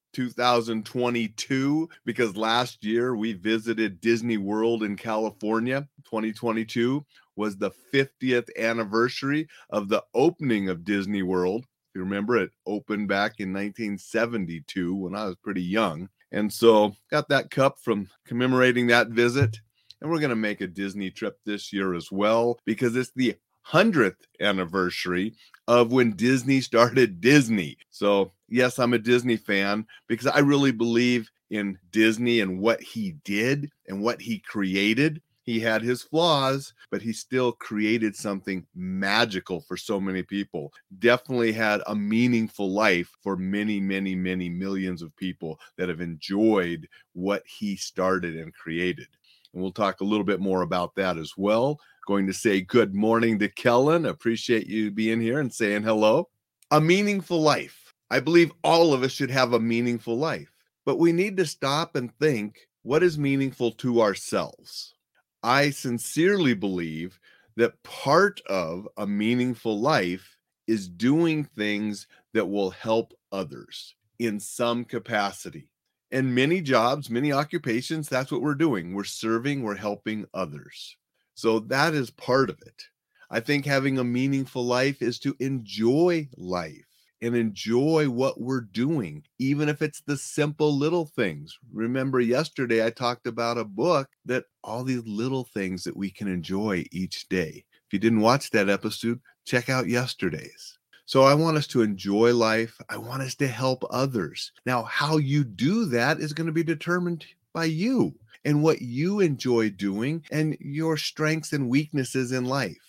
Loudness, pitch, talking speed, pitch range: -25 LUFS, 115 Hz, 155 wpm, 105-135 Hz